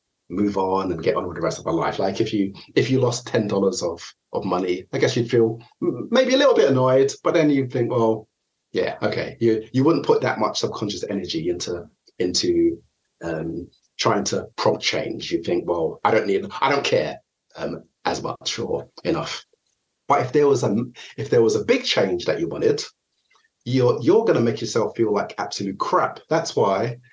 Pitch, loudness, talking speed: 130 Hz, -22 LUFS, 205 wpm